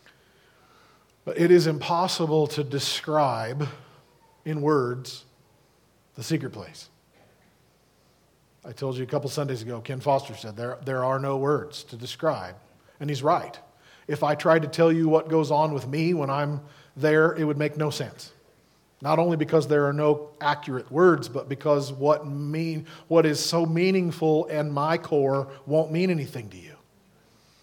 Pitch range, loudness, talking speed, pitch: 135-160 Hz, -25 LUFS, 160 wpm, 150 Hz